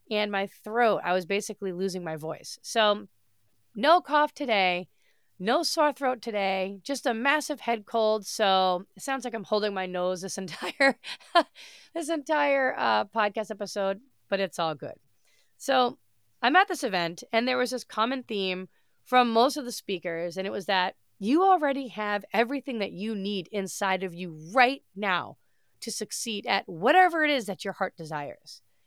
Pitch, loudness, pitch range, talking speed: 210 Hz, -27 LUFS, 185-255 Hz, 175 wpm